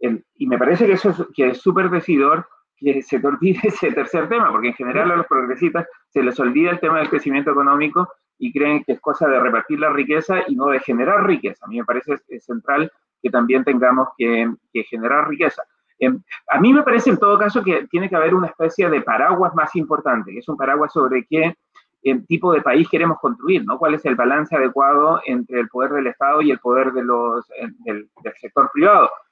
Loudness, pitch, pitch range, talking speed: -18 LUFS, 150 Hz, 125-180 Hz, 225 wpm